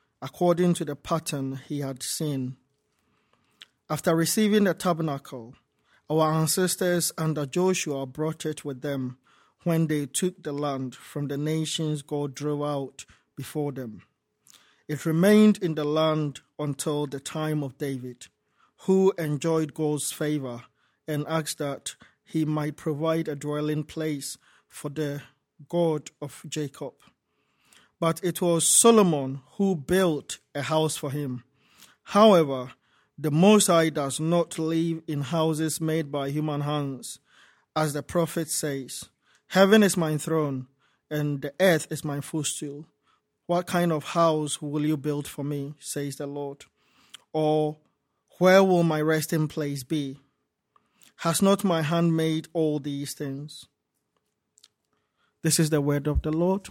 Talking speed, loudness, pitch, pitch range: 140 wpm, -26 LUFS, 155 Hz, 145-165 Hz